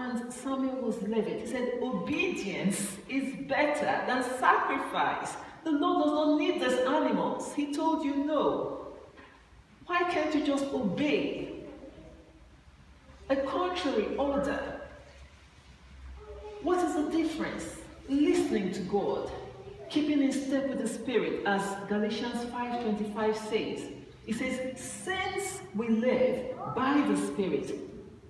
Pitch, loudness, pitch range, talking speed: 255 Hz, -30 LUFS, 215-295 Hz, 115 wpm